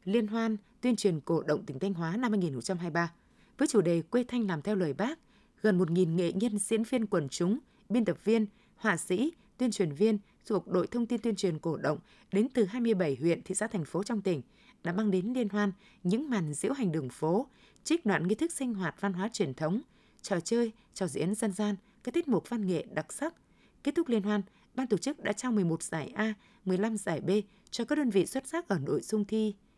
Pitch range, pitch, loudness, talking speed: 185-235 Hz, 205 Hz, -32 LUFS, 230 wpm